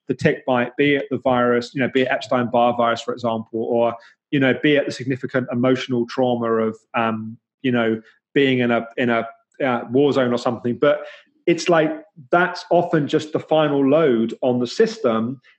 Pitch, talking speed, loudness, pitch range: 130 Hz, 190 wpm, -20 LUFS, 120-150 Hz